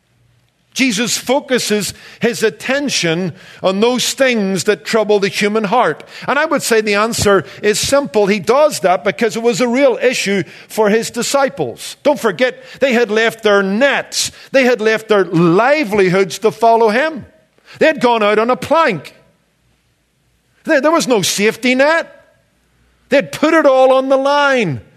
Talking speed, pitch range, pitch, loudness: 160 wpm, 205-265 Hz, 230 Hz, -14 LUFS